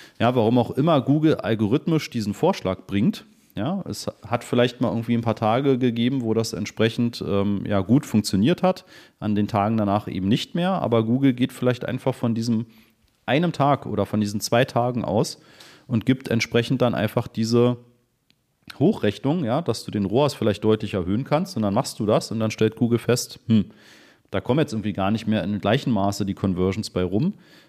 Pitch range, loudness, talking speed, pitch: 105-125 Hz, -23 LUFS, 195 wpm, 115 Hz